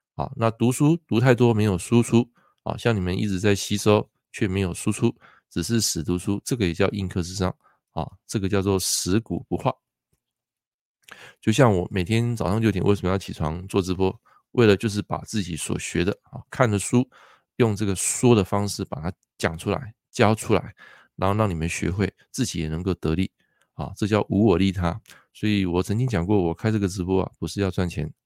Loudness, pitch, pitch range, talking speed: -24 LUFS, 100 Hz, 95-115 Hz, 285 characters per minute